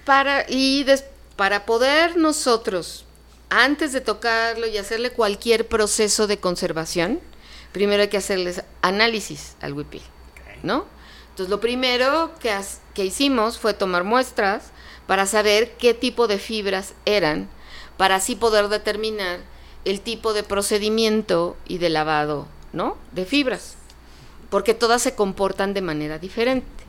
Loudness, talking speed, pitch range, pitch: -21 LUFS, 135 wpm, 195-235 Hz, 215 Hz